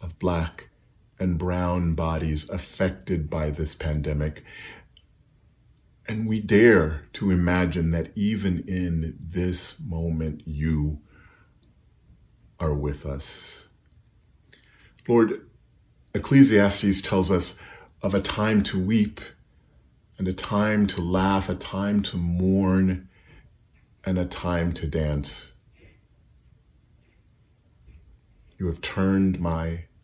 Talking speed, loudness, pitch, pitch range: 100 wpm, -25 LUFS, 90 Hz, 80-95 Hz